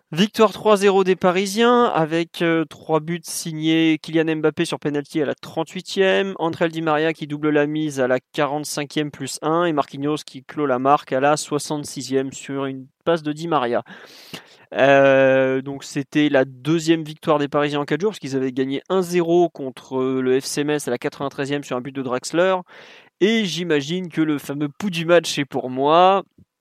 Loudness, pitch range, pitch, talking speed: -20 LUFS, 140-170 Hz, 150 Hz, 185 wpm